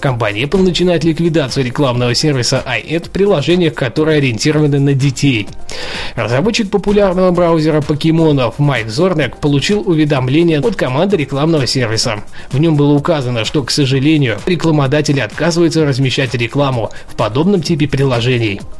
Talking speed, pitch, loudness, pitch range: 130 wpm, 150 Hz, -13 LUFS, 135-165 Hz